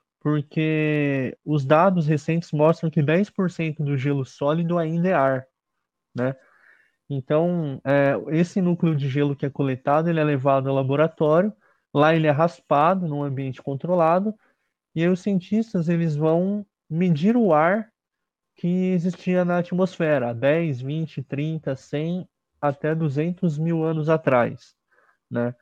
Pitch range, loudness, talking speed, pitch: 145-175 Hz, -22 LUFS, 135 wpm, 155 Hz